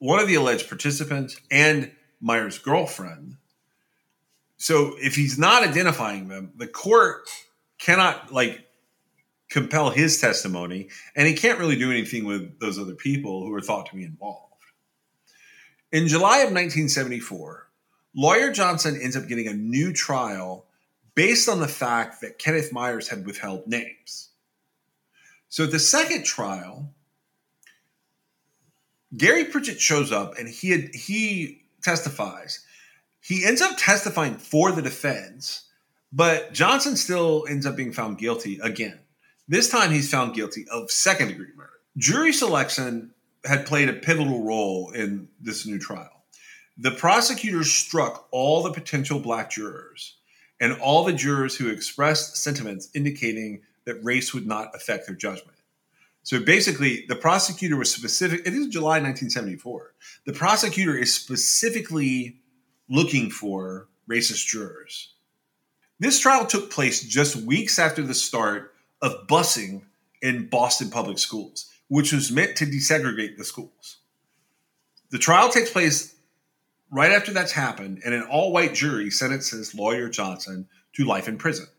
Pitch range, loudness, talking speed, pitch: 115-160 Hz, -22 LUFS, 140 wpm, 140 Hz